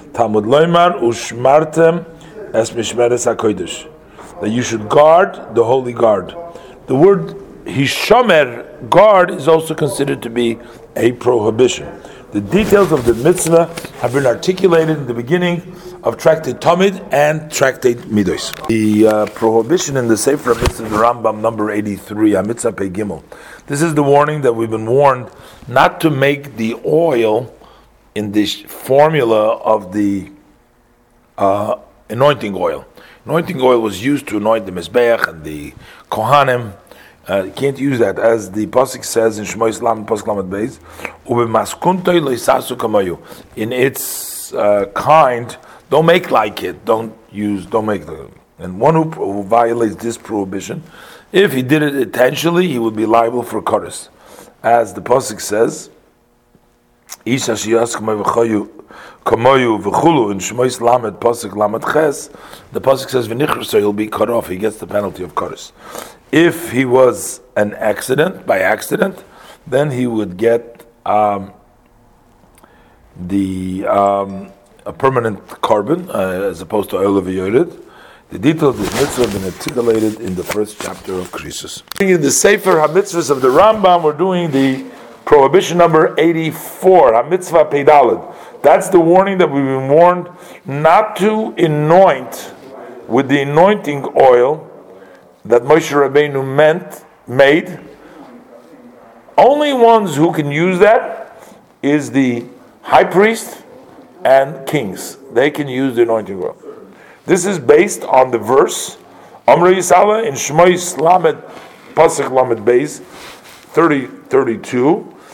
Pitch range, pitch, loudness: 110-160 Hz, 125 Hz, -14 LUFS